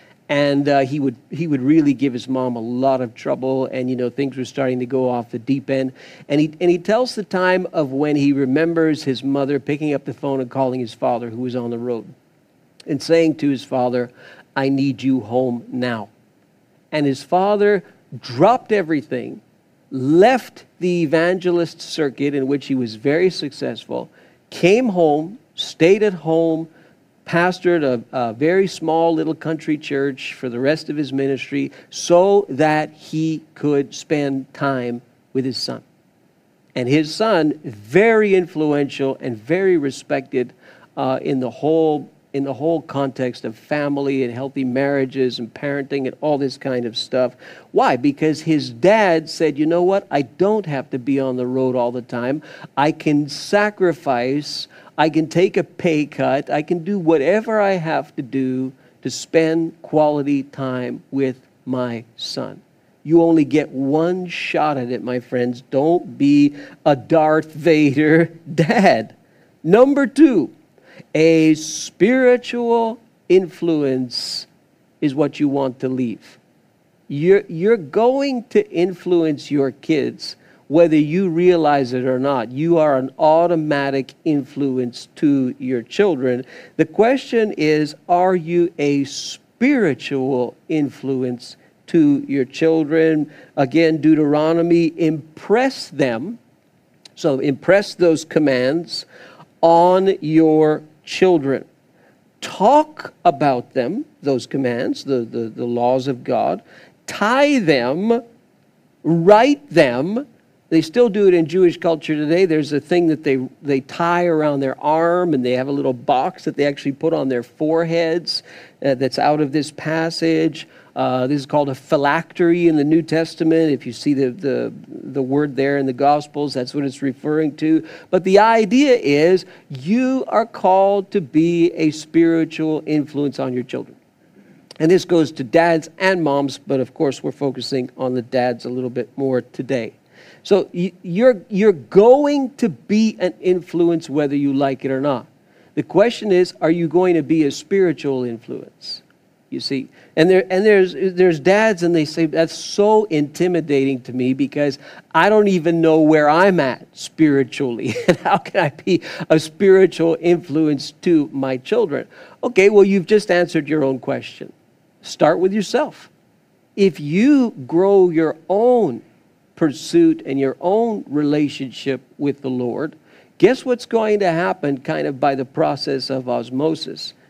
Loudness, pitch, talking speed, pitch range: -18 LUFS, 155 Hz, 155 wpm, 135-175 Hz